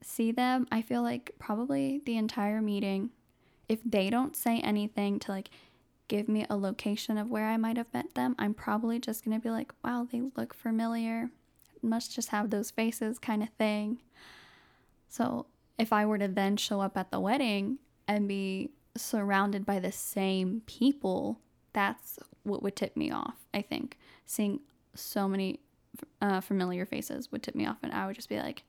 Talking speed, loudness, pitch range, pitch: 180 wpm, -33 LUFS, 200-235 Hz, 220 Hz